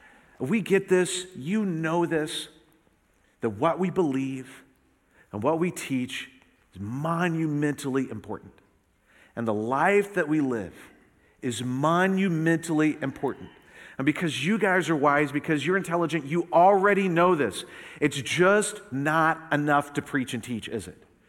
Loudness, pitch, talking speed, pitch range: -25 LUFS, 155 Hz, 140 wpm, 135-175 Hz